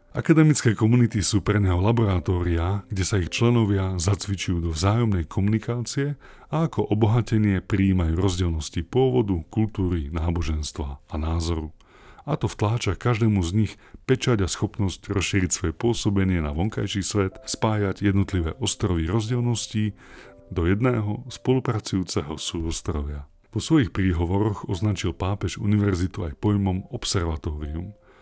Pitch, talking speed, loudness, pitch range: 100 Hz, 120 wpm, -24 LUFS, 90-110 Hz